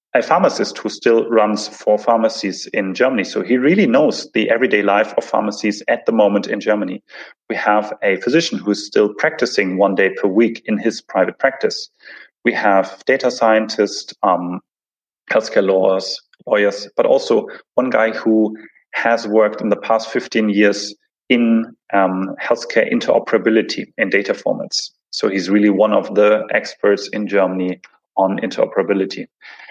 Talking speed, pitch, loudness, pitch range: 160 wpm, 105 Hz, -17 LUFS, 100-115 Hz